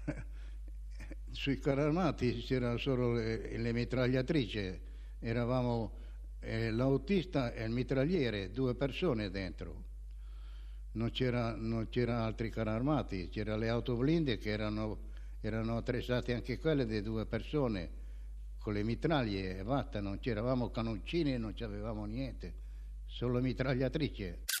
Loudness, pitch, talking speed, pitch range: -36 LUFS, 115 Hz, 115 wpm, 95-125 Hz